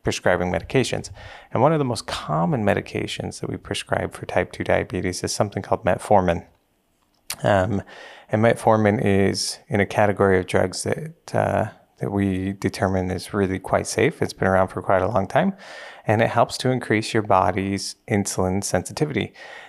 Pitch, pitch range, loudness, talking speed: 100 Hz, 95-110 Hz, -22 LUFS, 170 wpm